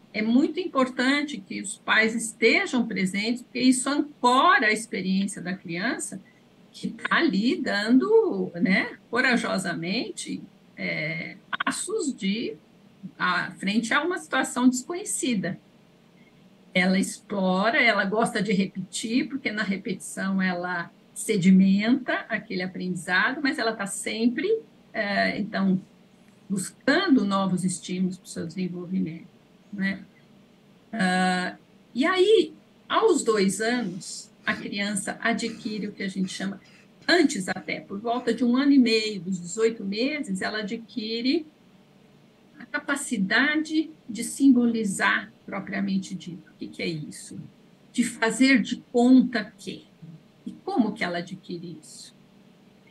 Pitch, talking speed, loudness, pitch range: 215 Hz, 120 wpm, -25 LUFS, 195-250 Hz